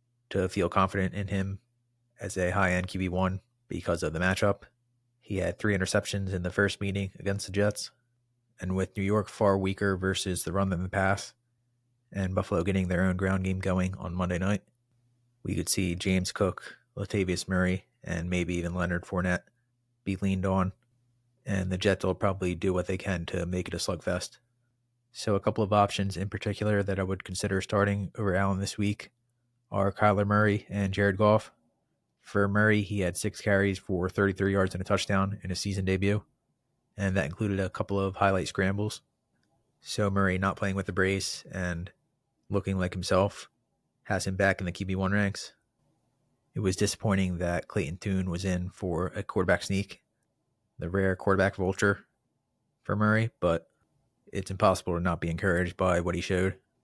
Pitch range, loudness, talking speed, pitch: 95-105 Hz, -29 LUFS, 180 wpm, 95 Hz